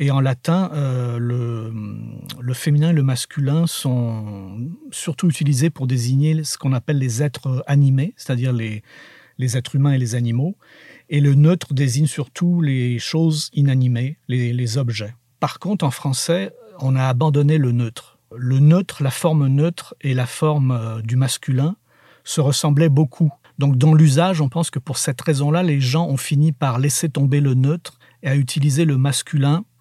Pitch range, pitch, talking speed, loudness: 130-155 Hz, 140 Hz, 175 wpm, -19 LUFS